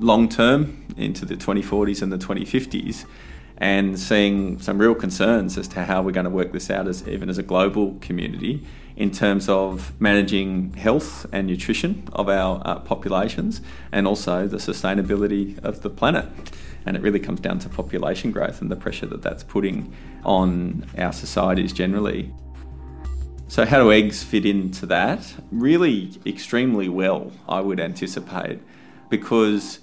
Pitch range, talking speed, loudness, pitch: 90-105 Hz, 155 wpm, -22 LUFS, 95 Hz